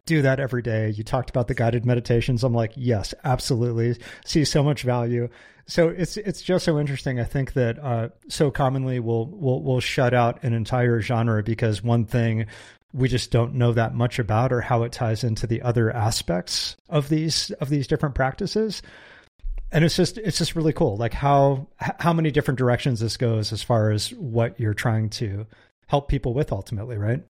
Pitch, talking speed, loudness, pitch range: 125 Hz, 195 wpm, -23 LUFS, 115-145 Hz